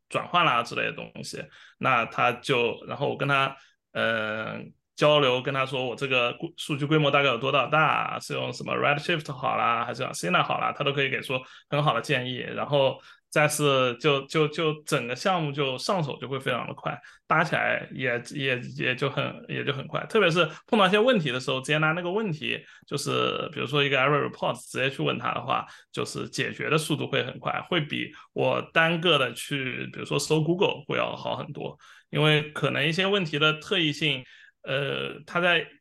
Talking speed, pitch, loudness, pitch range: 325 characters per minute, 145 Hz, -26 LUFS, 135-155 Hz